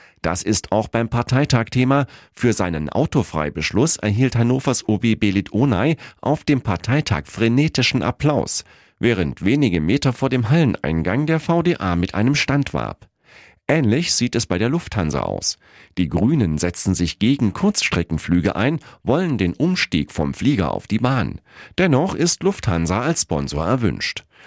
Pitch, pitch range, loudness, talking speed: 120 Hz, 90-140 Hz, -19 LUFS, 140 wpm